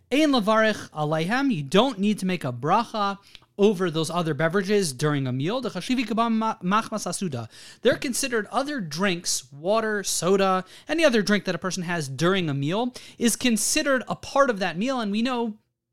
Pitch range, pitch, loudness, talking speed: 175-230 Hz, 205 Hz, -24 LUFS, 165 wpm